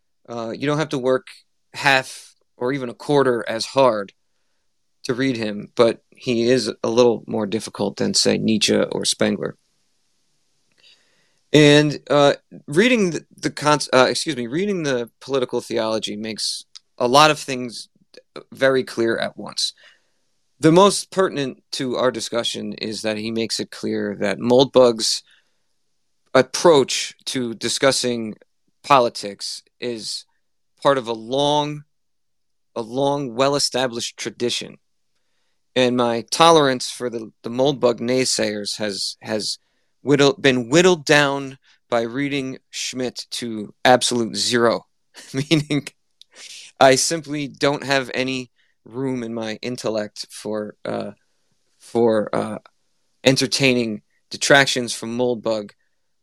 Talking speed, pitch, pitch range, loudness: 125 wpm, 125 Hz, 115-140 Hz, -20 LUFS